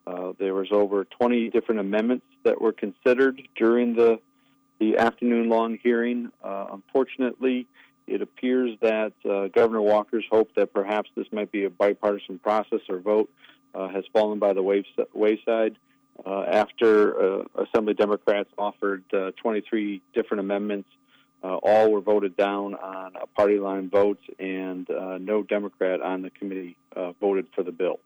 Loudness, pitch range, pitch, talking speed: -25 LUFS, 100-115 Hz, 105 Hz, 160 wpm